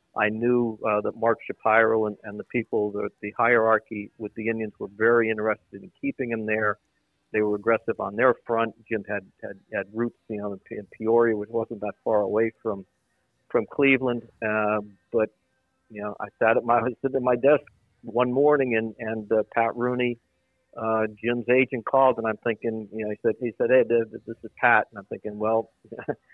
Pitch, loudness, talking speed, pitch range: 110 Hz, -25 LUFS, 195 wpm, 105-120 Hz